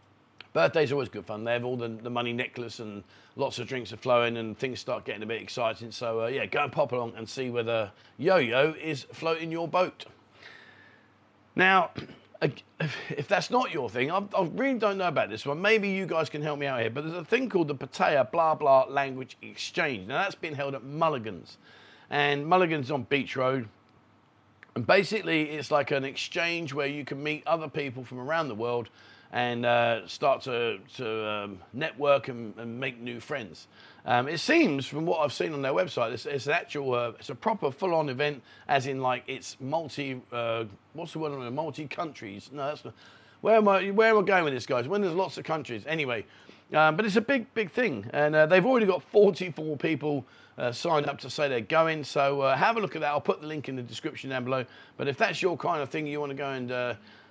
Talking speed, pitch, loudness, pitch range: 225 wpm, 140 Hz, -28 LUFS, 120-160 Hz